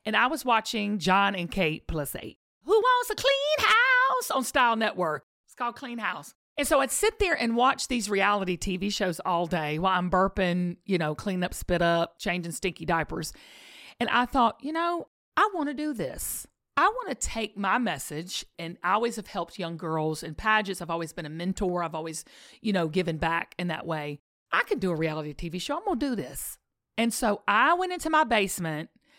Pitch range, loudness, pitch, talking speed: 170-265 Hz, -27 LUFS, 200 Hz, 210 wpm